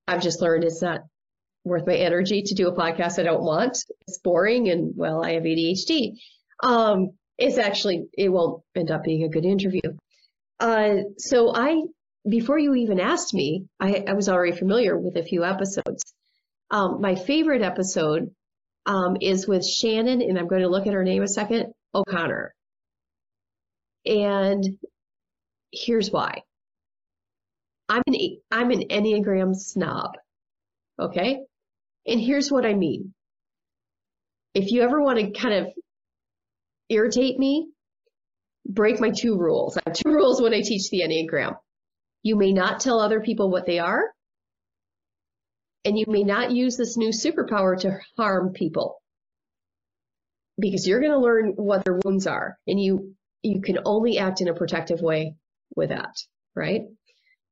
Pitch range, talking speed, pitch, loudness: 175-230 Hz, 155 wpm, 195 Hz, -23 LUFS